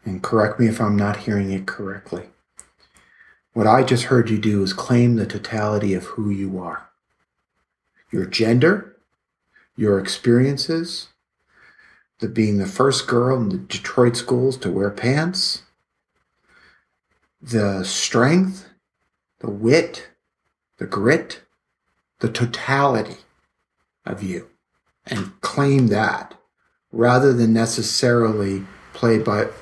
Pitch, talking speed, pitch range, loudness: 115 Hz, 115 wpm, 105-125 Hz, -20 LUFS